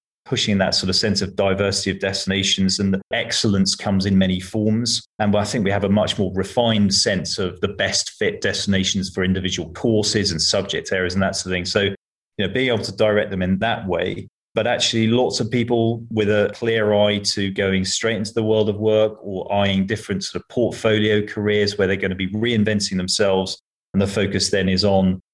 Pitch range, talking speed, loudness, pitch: 95-110 Hz, 215 wpm, -20 LUFS, 100 Hz